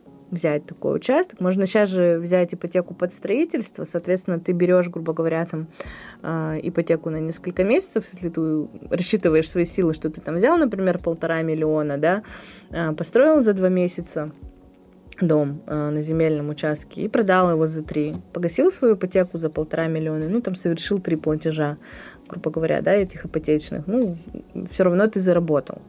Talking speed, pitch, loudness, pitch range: 155 wpm, 170 Hz, -22 LUFS, 155-185 Hz